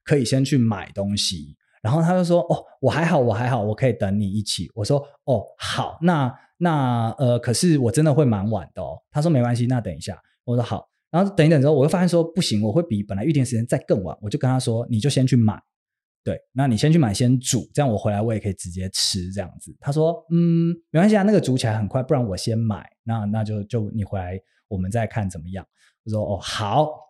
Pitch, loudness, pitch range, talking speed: 120 Hz, -21 LUFS, 105-155 Hz, 335 characters per minute